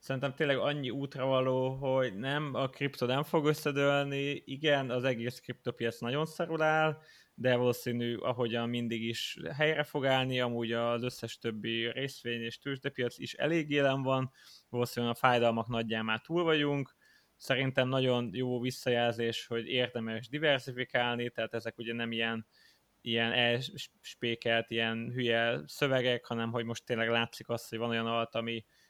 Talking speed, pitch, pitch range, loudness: 150 wpm, 125 Hz, 115-135 Hz, -32 LUFS